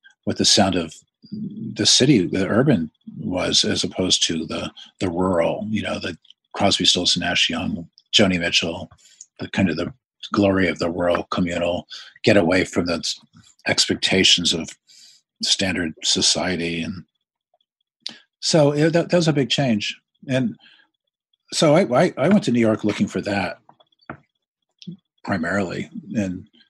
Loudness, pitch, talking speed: -19 LUFS, 105 Hz, 145 wpm